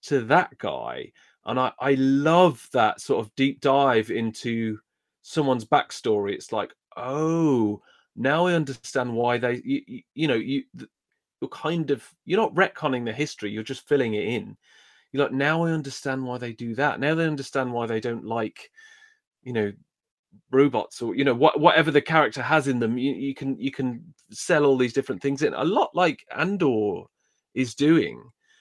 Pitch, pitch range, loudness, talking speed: 135 Hz, 120-155 Hz, -24 LUFS, 180 wpm